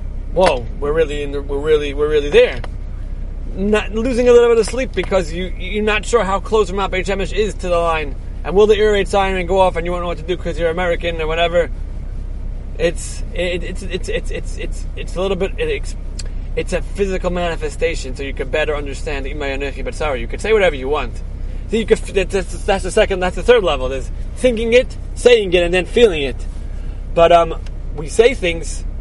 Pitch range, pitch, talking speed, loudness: 175-245 Hz, 195 Hz, 215 wpm, -17 LUFS